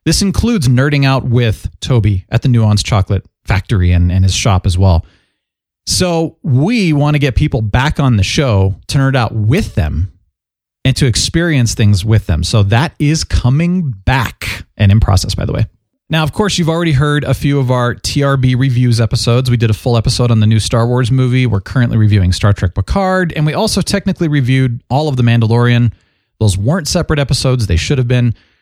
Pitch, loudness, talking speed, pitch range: 120 Hz, -13 LUFS, 200 wpm, 105-145 Hz